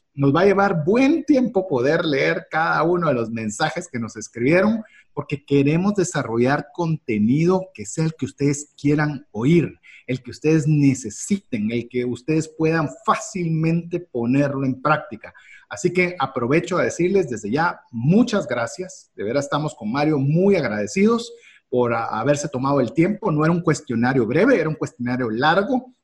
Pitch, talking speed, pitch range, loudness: 155 Hz, 160 wpm, 130-180 Hz, -21 LUFS